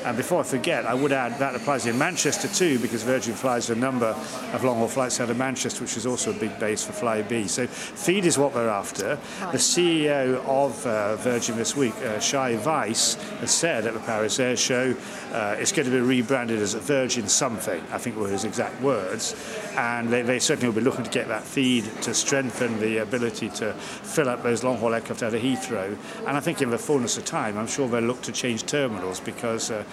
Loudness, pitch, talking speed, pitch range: -25 LUFS, 125 Hz, 225 wpm, 115-135 Hz